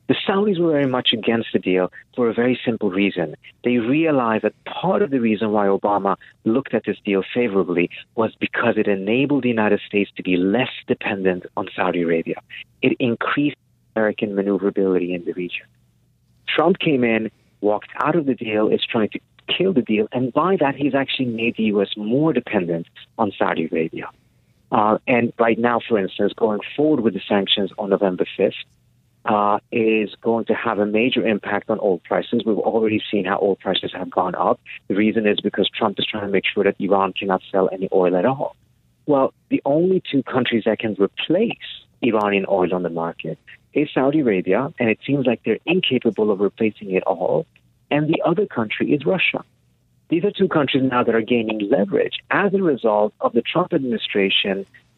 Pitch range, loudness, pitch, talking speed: 100-125 Hz, -20 LUFS, 110 Hz, 190 wpm